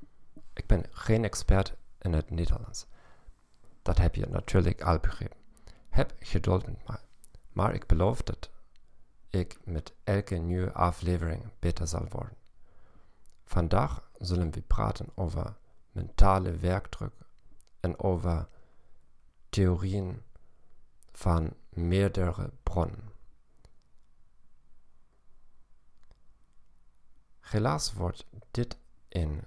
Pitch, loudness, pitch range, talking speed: 90 Hz, -31 LUFS, 85-105 Hz, 95 wpm